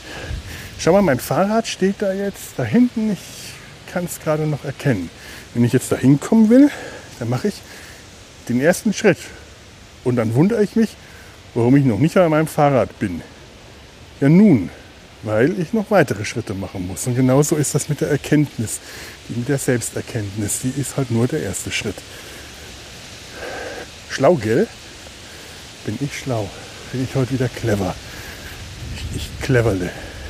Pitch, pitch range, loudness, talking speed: 130 Hz, 105-155 Hz, -19 LUFS, 160 wpm